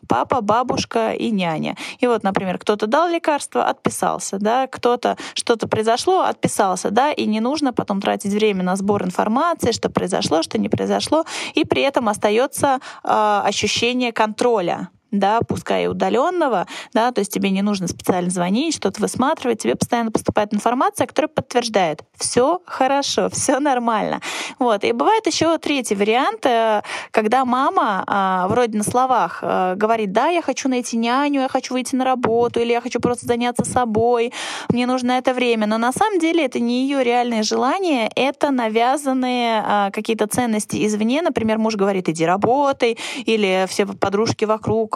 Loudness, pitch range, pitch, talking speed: -19 LUFS, 215-265 Hz, 235 Hz, 155 wpm